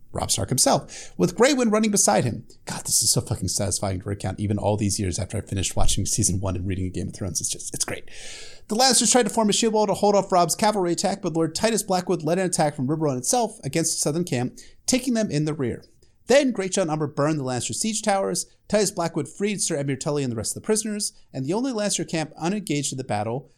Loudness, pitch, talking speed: -23 LUFS, 160 Hz, 250 wpm